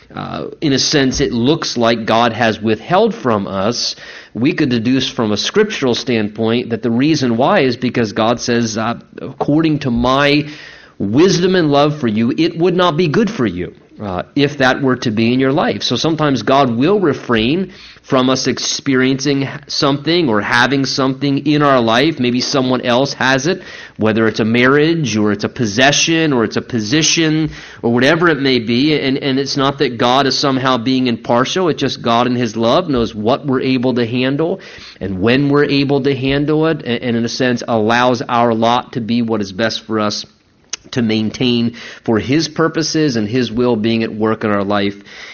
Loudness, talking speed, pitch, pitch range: -15 LUFS, 195 wpm, 130 Hz, 115-145 Hz